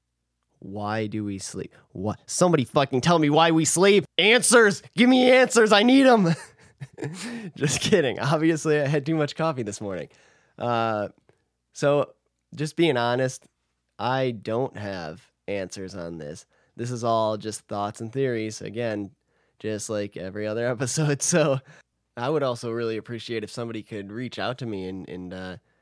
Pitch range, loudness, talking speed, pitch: 105-155 Hz, -23 LUFS, 160 wpm, 120 Hz